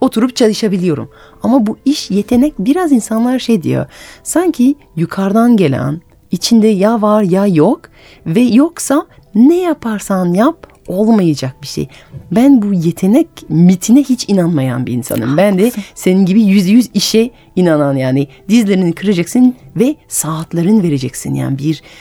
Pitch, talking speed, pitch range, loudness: 205 Hz, 135 wpm, 170-240 Hz, -12 LUFS